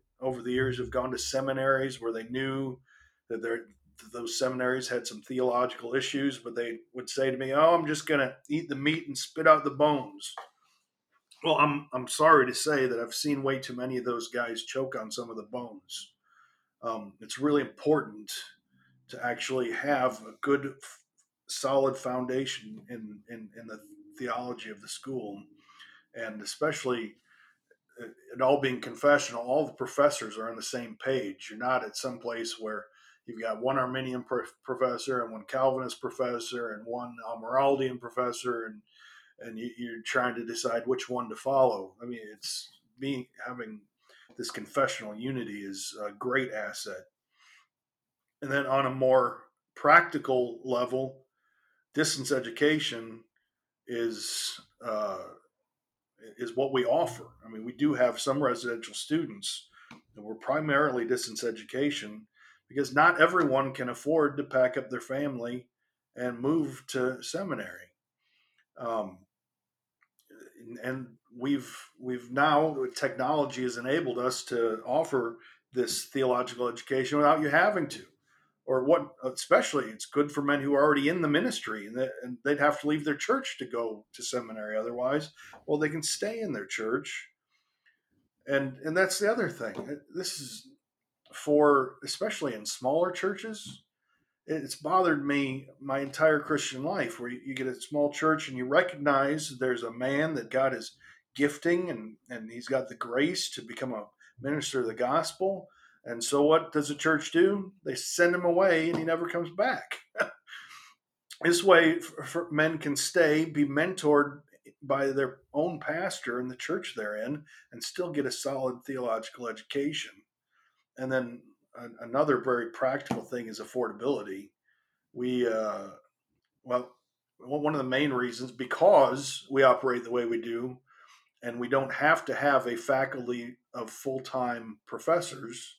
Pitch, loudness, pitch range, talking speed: 130 Hz, -29 LUFS, 120-145 Hz, 155 wpm